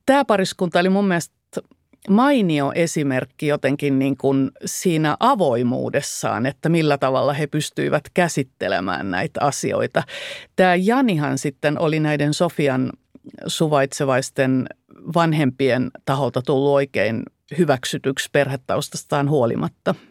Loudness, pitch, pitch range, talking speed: -20 LUFS, 150 Hz, 135-170 Hz, 100 wpm